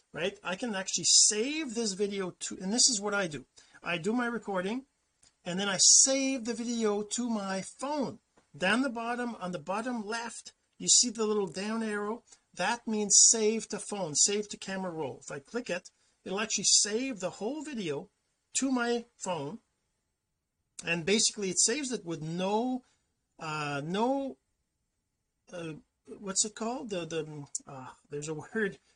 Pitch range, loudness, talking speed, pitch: 185-235 Hz, -29 LUFS, 170 wpm, 210 Hz